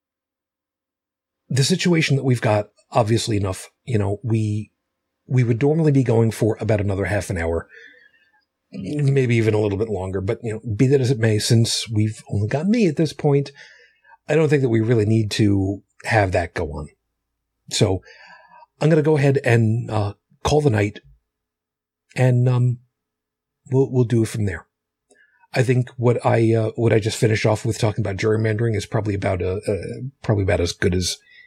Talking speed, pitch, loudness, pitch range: 185 wpm, 115 Hz, -20 LUFS, 105-135 Hz